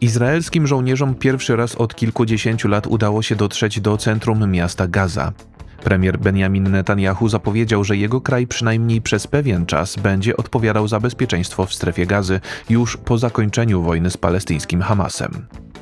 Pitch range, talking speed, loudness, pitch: 95-120 Hz, 150 wpm, -18 LUFS, 110 Hz